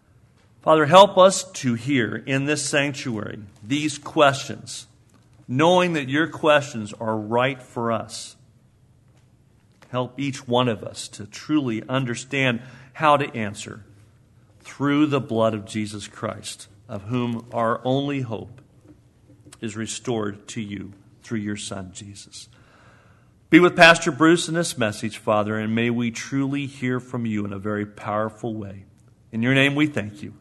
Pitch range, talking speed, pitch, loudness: 110-135 Hz, 145 wpm, 120 Hz, -21 LUFS